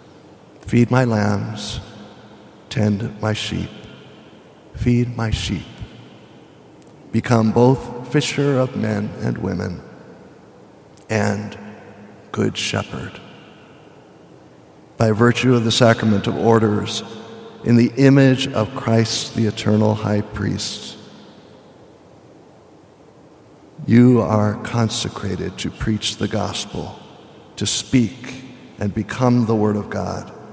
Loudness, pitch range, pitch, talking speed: -19 LUFS, 105-120 Hz, 110 Hz, 100 wpm